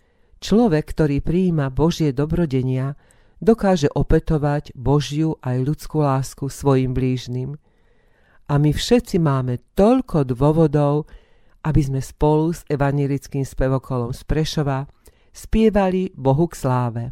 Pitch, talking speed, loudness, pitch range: 145 Hz, 110 wpm, -20 LUFS, 135-160 Hz